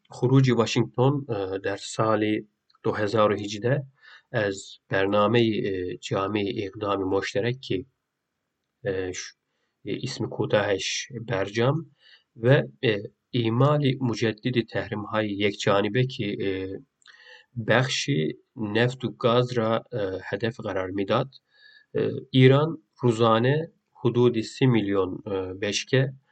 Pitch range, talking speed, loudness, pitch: 100-130 Hz, 90 wpm, -25 LUFS, 115 Hz